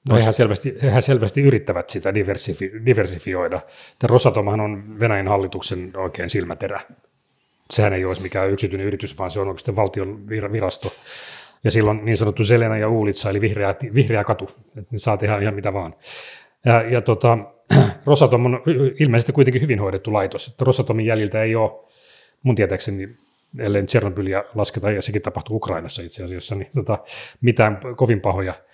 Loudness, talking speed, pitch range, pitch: -20 LUFS, 155 wpm, 100-120 Hz, 110 Hz